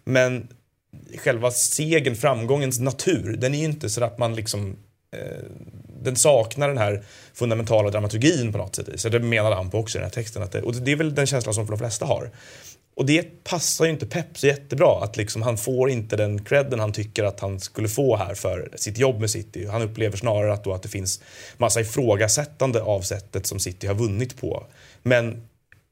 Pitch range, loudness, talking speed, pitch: 105-130 Hz, -23 LUFS, 205 wpm, 115 Hz